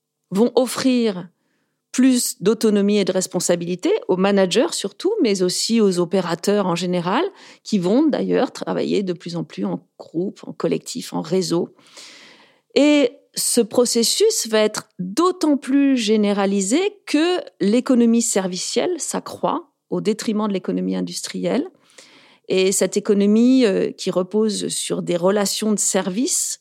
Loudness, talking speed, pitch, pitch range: -19 LUFS, 130 wpm, 215 Hz, 185-260 Hz